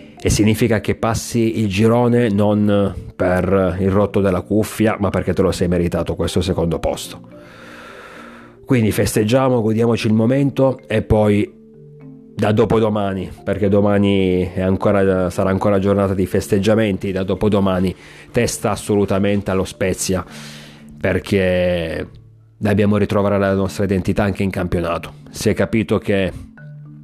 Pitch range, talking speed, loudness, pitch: 90-110 Hz, 130 wpm, -17 LUFS, 100 Hz